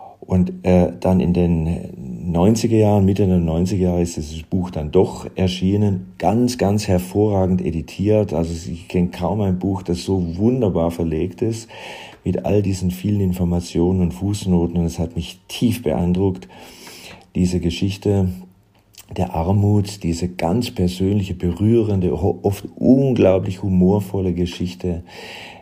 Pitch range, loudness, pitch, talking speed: 85-100 Hz, -19 LUFS, 90 Hz, 135 wpm